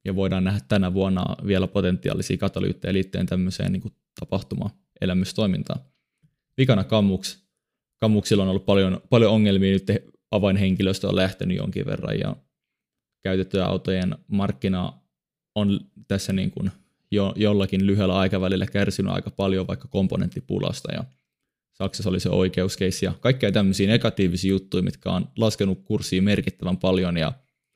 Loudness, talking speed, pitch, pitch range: -24 LUFS, 130 wpm, 95 Hz, 95-100 Hz